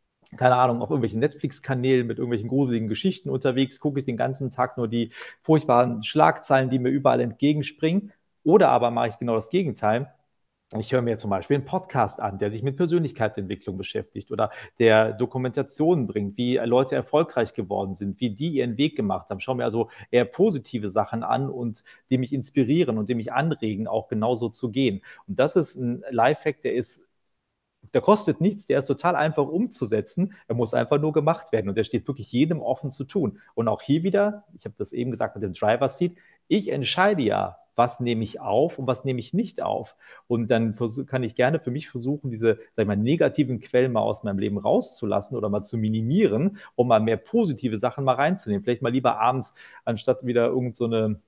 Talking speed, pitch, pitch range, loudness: 200 wpm, 125 Hz, 115-145 Hz, -24 LUFS